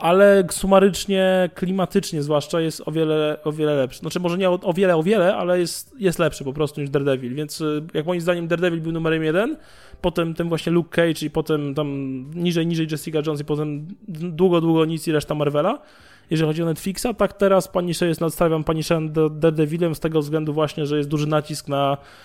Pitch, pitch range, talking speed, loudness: 160 Hz, 150-180 Hz, 195 wpm, -21 LUFS